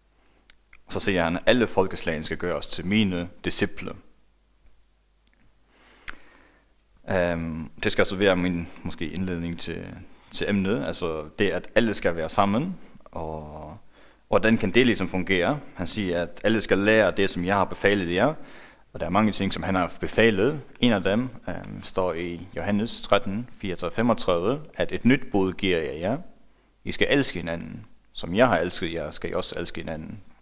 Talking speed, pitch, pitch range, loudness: 175 wpm, 90 Hz, 85-100 Hz, -25 LUFS